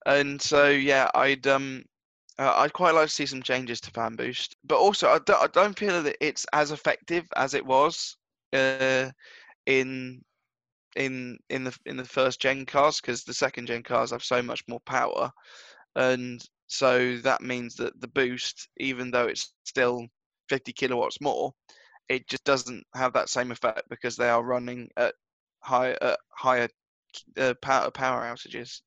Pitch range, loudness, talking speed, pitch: 125-135 Hz, -26 LUFS, 175 wpm, 130 Hz